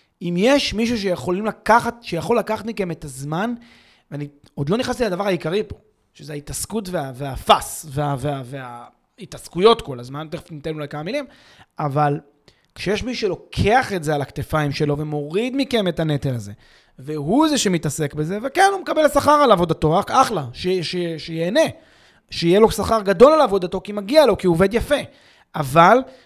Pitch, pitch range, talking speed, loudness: 180 Hz, 150-230 Hz, 170 wpm, -19 LUFS